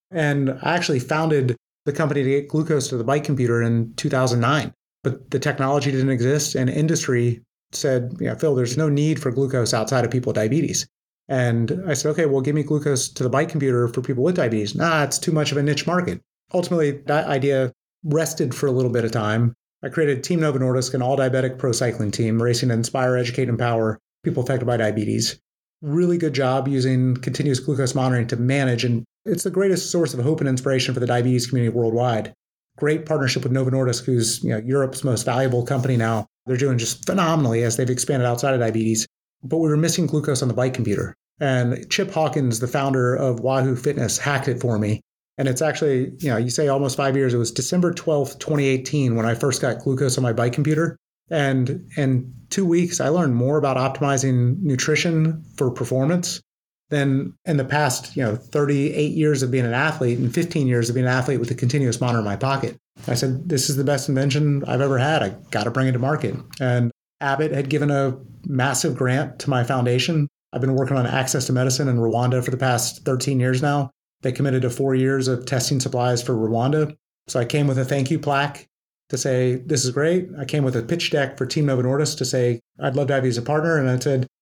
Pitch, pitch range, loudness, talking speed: 135 Hz, 125-150 Hz, -21 LUFS, 215 wpm